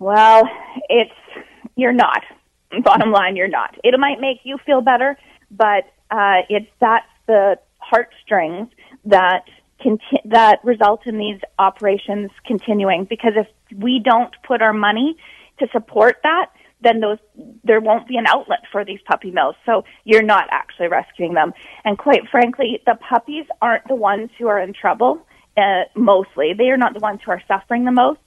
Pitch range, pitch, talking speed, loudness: 205-250 Hz, 225 Hz, 170 wpm, -16 LUFS